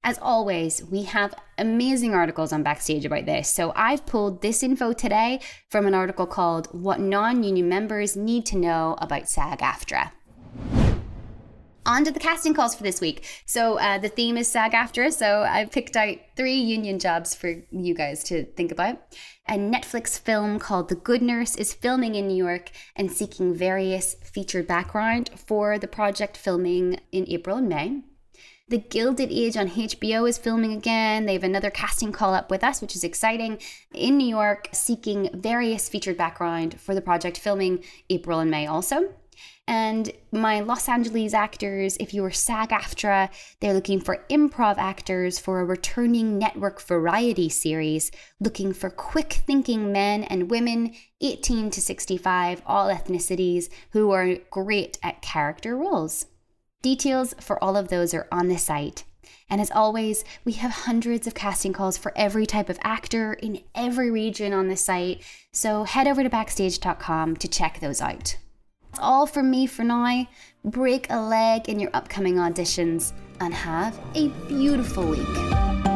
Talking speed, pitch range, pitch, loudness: 165 wpm, 180-230 Hz, 205 Hz, -24 LUFS